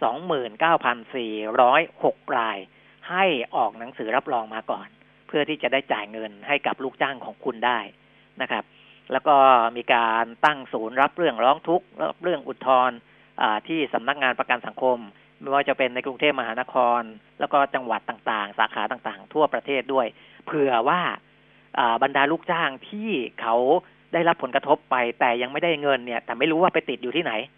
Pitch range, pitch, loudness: 115-150 Hz, 130 Hz, -23 LUFS